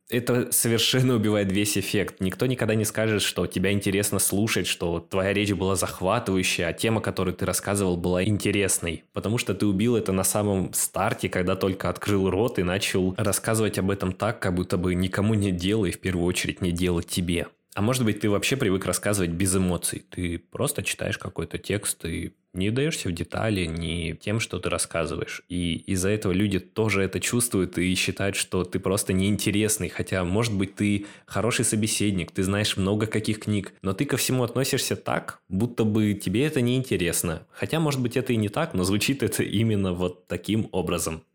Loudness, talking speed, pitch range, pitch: -25 LUFS, 185 wpm, 90-110 Hz, 100 Hz